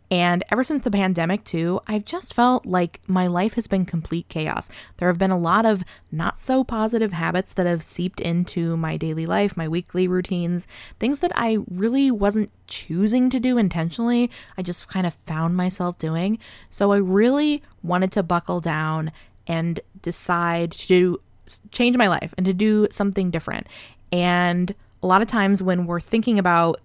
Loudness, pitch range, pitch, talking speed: -22 LUFS, 175-215 Hz, 185 Hz, 175 wpm